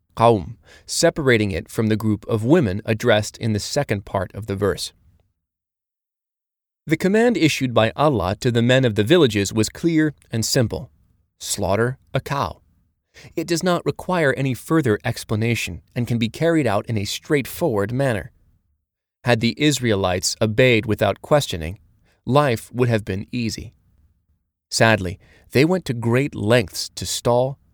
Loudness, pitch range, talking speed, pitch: -20 LUFS, 100-130 Hz, 145 wpm, 110 Hz